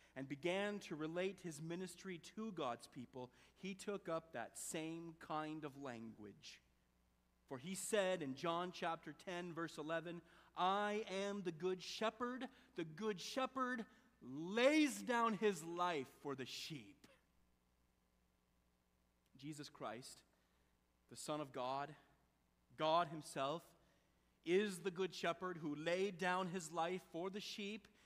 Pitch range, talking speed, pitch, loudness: 130-190 Hz, 130 wpm, 165 Hz, -44 LUFS